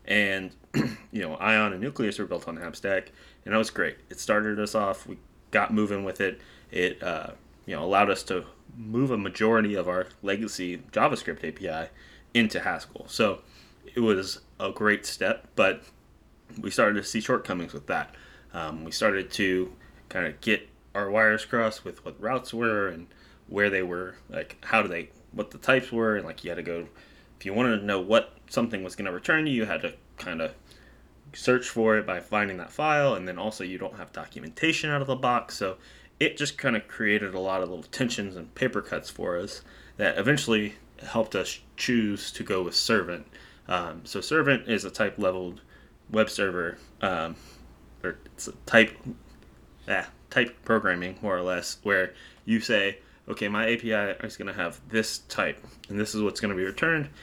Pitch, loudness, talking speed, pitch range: 105 Hz, -27 LUFS, 195 wpm, 90-110 Hz